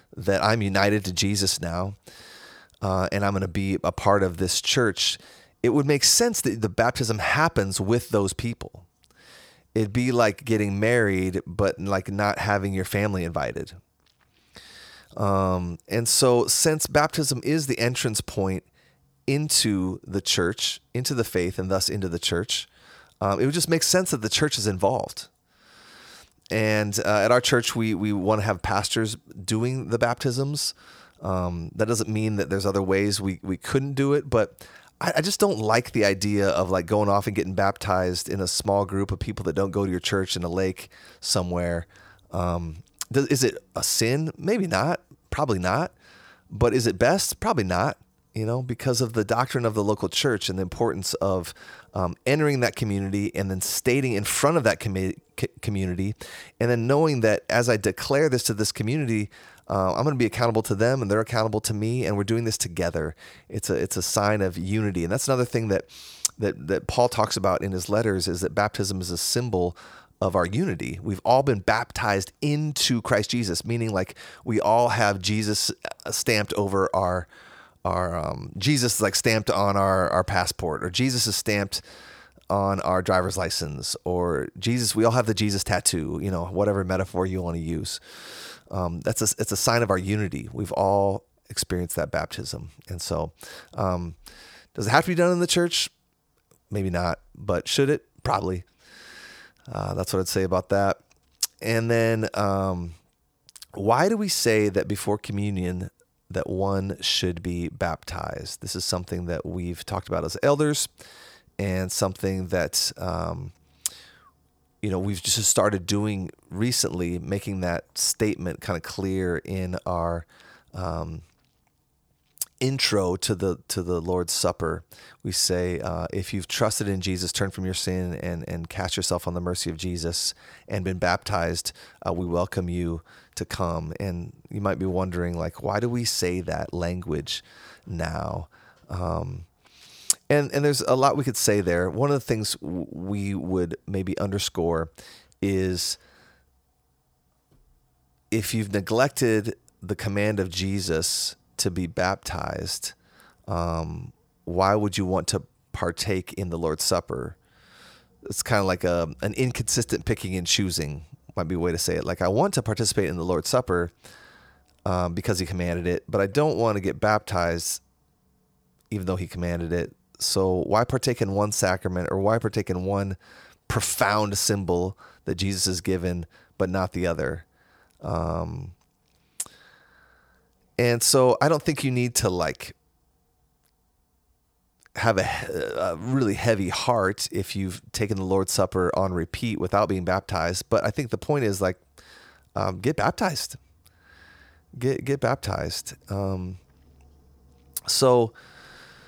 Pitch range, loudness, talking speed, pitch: 90-115 Hz, -25 LUFS, 170 wpm, 100 Hz